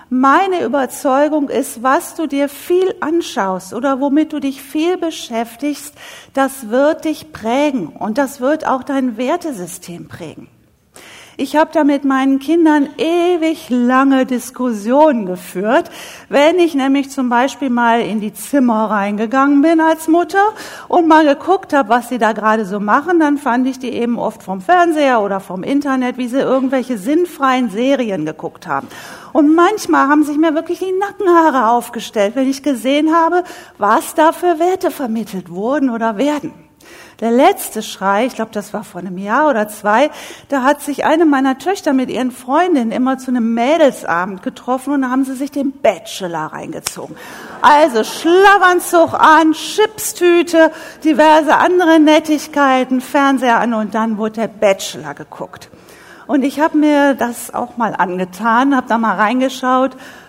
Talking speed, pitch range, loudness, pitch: 155 wpm, 235-315 Hz, -14 LUFS, 275 Hz